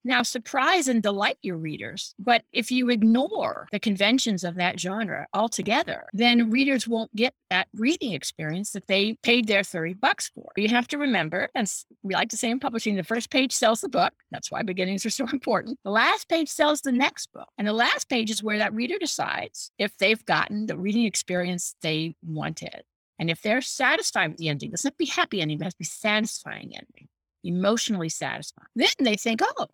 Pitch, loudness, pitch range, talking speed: 225 Hz, -25 LUFS, 195-255 Hz, 210 wpm